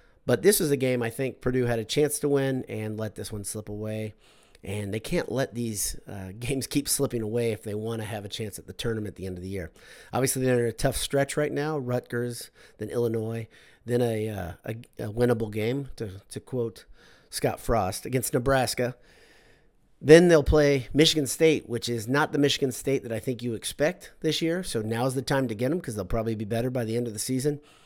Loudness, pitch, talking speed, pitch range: -27 LUFS, 120 Hz, 230 wpm, 110-135 Hz